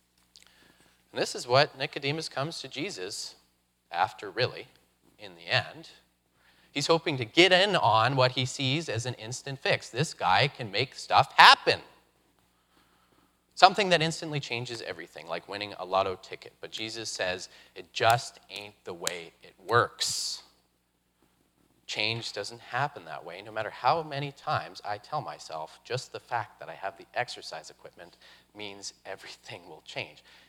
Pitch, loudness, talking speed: 110 Hz, -27 LUFS, 155 wpm